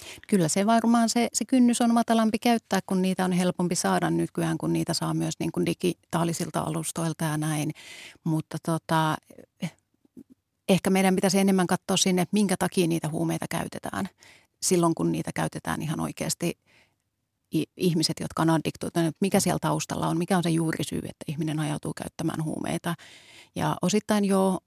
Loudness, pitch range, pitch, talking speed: -26 LUFS, 160-195 Hz, 175 Hz, 155 wpm